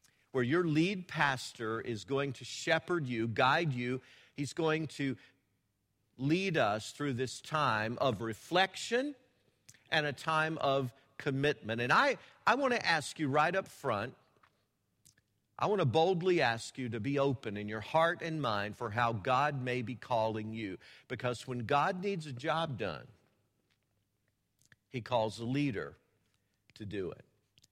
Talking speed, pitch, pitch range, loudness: 155 wpm, 130 Hz, 115-155 Hz, -33 LUFS